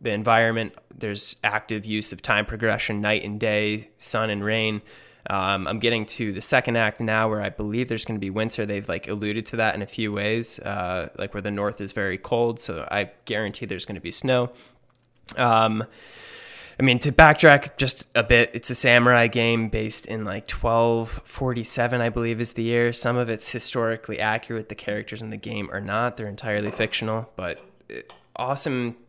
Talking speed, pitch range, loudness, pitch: 195 wpm, 105-120 Hz, -22 LUFS, 110 Hz